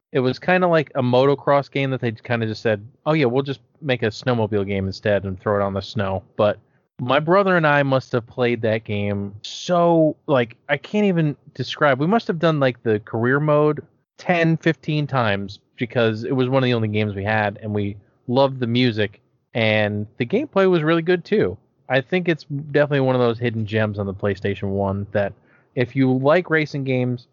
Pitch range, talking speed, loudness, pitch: 110-145 Hz, 215 wpm, -21 LUFS, 125 Hz